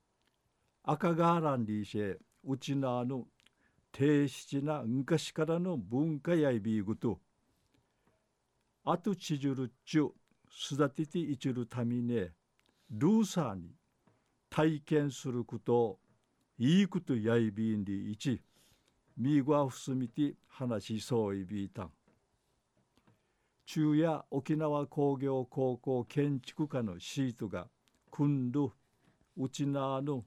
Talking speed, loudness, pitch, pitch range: 215 characters per minute, -34 LUFS, 135 Hz, 120-150 Hz